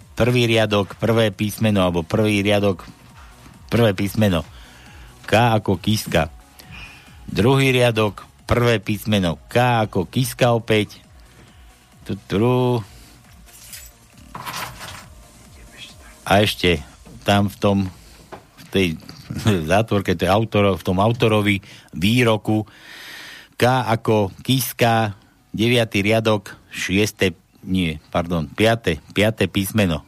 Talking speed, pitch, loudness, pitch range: 90 wpm, 105 Hz, -19 LUFS, 95-115 Hz